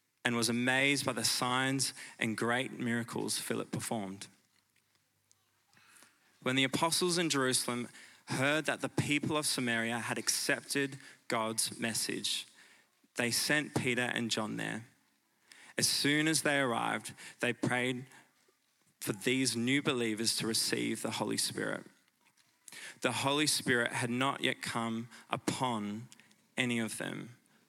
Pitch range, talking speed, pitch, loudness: 115-140 Hz, 130 wpm, 125 Hz, -33 LUFS